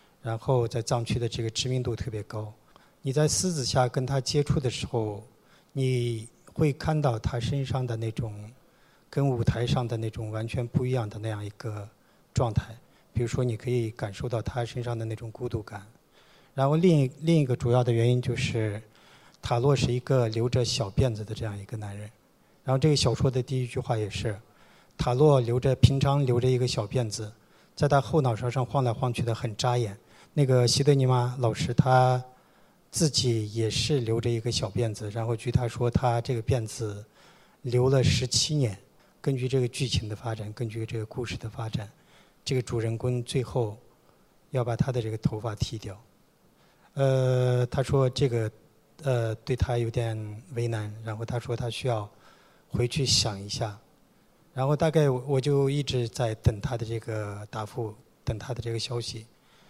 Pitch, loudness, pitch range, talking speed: 120 Hz, -28 LUFS, 115-135 Hz, 260 characters per minute